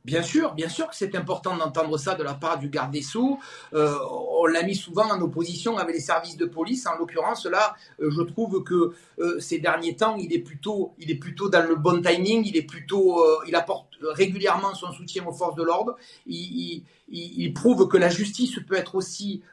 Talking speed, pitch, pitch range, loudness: 210 wpm, 170 Hz, 165-195 Hz, -25 LUFS